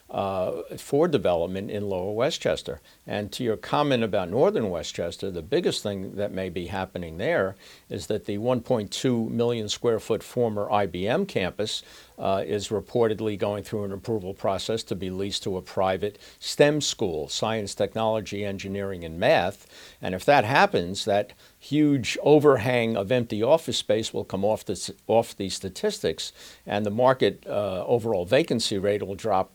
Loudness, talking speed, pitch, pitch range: -26 LUFS, 155 wpm, 105 Hz, 100-115 Hz